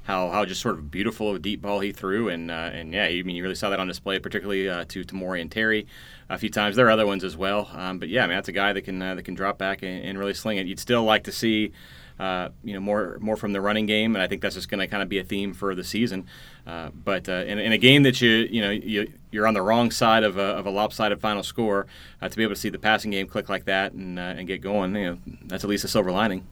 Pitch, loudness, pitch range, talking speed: 100 Hz, -24 LUFS, 95-105 Hz, 310 wpm